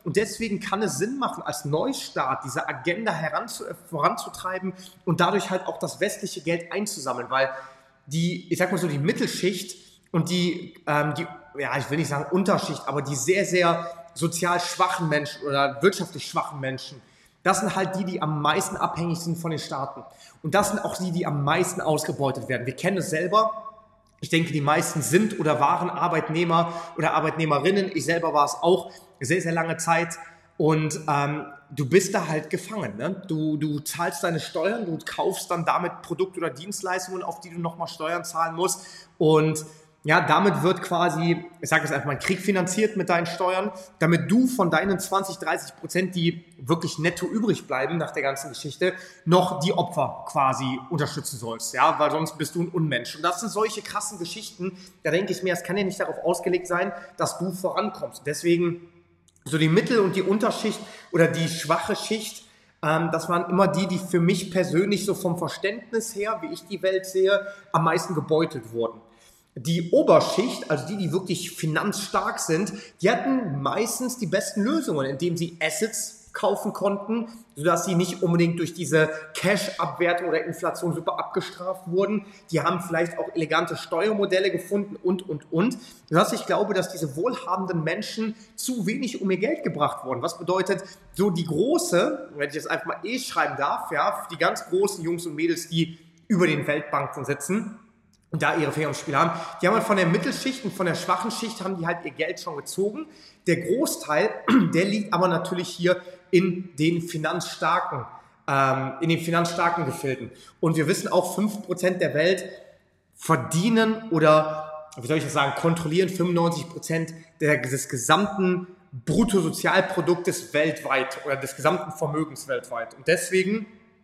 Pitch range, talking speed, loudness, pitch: 155-190 Hz, 175 wpm, -25 LUFS, 175 Hz